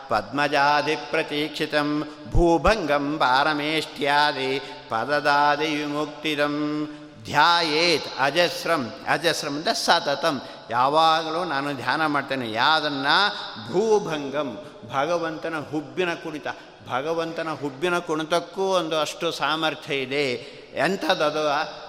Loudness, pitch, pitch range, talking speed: -23 LUFS, 150 Hz, 145-160 Hz, 70 wpm